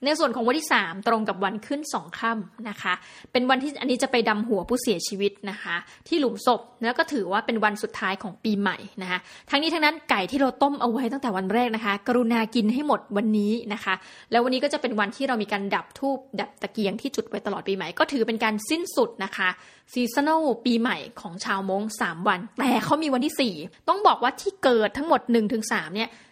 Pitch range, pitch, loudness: 205-265 Hz, 230 Hz, -25 LUFS